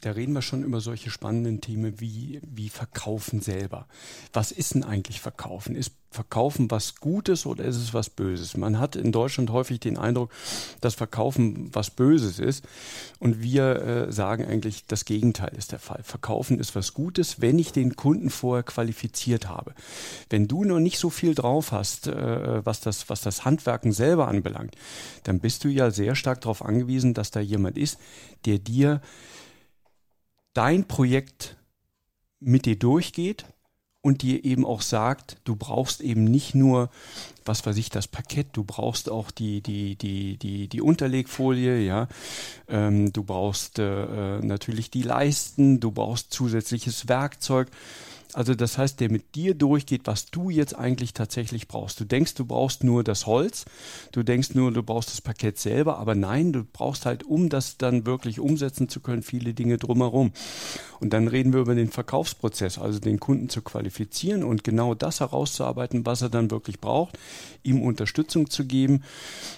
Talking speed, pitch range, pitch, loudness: 170 wpm, 110-135 Hz, 120 Hz, -26 LUFS